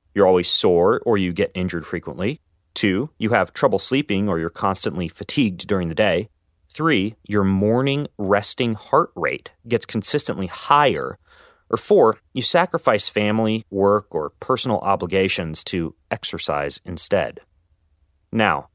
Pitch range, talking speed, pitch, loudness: 90-110 Hz, 135 wpm, 100 Hz, -20 LUFS